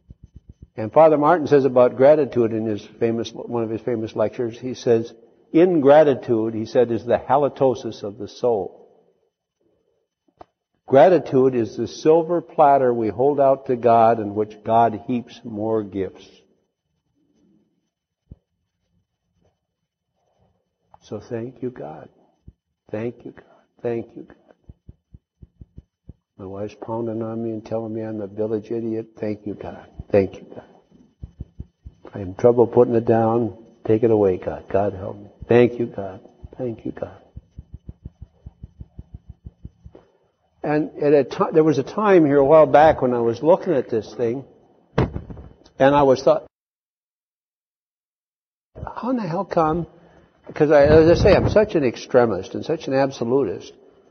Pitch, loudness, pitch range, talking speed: 120 Hz, -19 LUFS, 110-145 Hz, 145 wpm